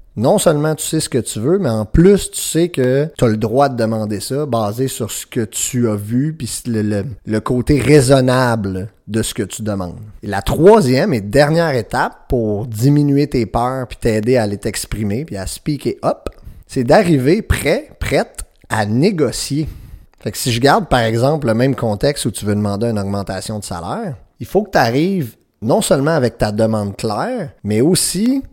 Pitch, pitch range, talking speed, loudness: 120 Hz, 105-145 Hz, 200 wpm, -16 LUFS